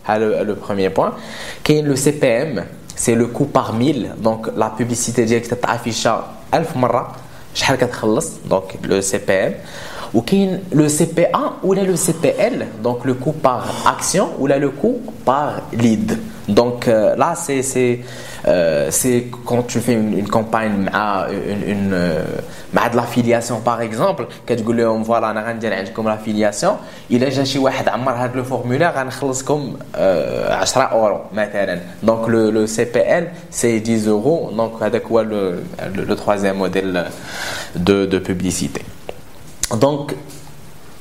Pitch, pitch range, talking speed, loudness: 120 Hz, 110-130 Hz, 145 wpm, -18 LUFS